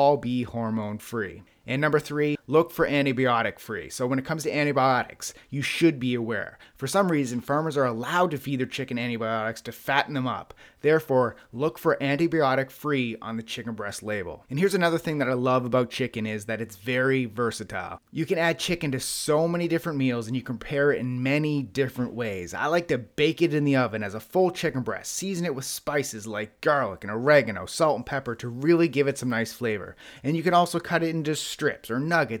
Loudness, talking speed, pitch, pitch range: -26 LUFS, 220 wpm, 135 Hz, 120-150 Hz